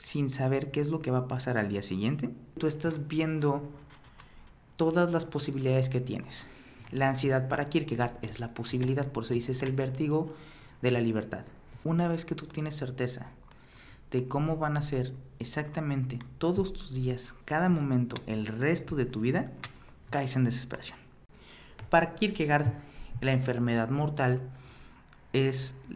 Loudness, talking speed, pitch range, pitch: -31 LUFS, 155 wpm, 125-150 Hz, 135 Hz